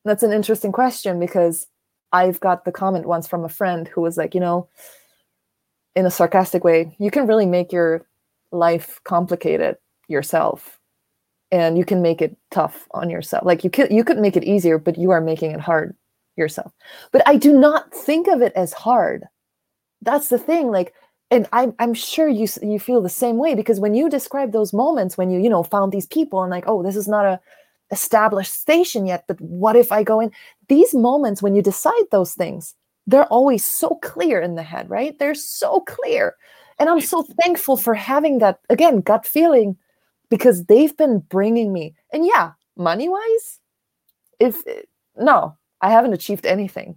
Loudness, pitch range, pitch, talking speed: -18 LUFS, 180-275 Hz, 210 Hz, 190 wpm